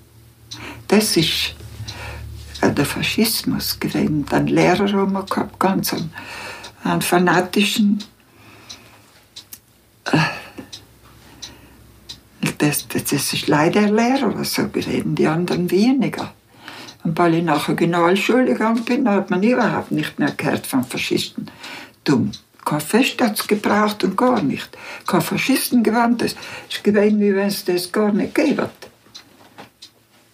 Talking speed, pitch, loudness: 125 wpm, 185 Hz, -19 LUFS